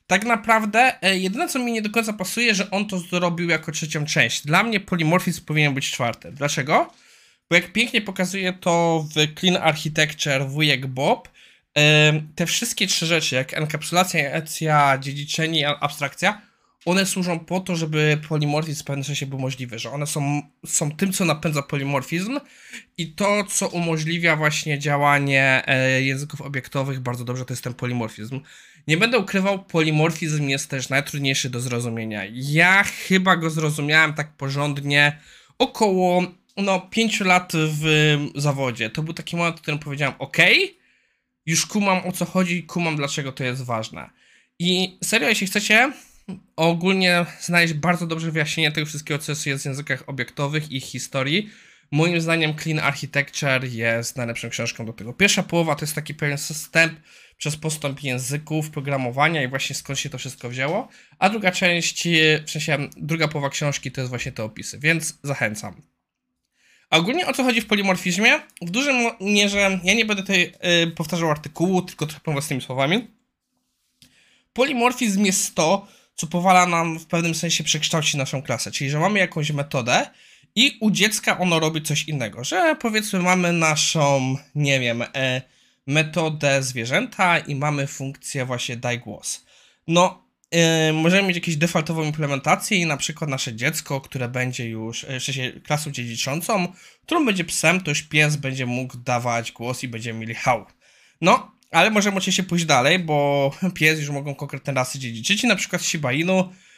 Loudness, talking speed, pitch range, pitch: -21 LUFS, 160 wpm, 140-180 Hz, 155 Hz